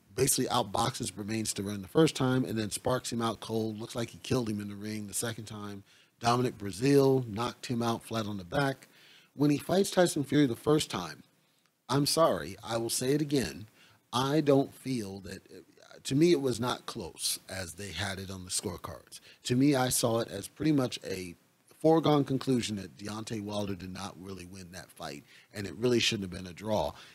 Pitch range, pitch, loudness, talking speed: 100-135 Hz, 115 Hz, -30 LUFS, 210 wpm